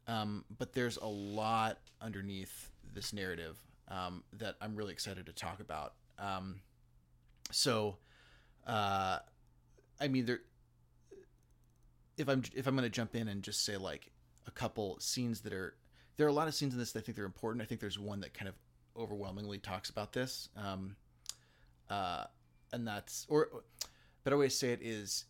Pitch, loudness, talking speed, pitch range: 100 Hz, -39 LUFS, 180 wpm, 75-115 Hz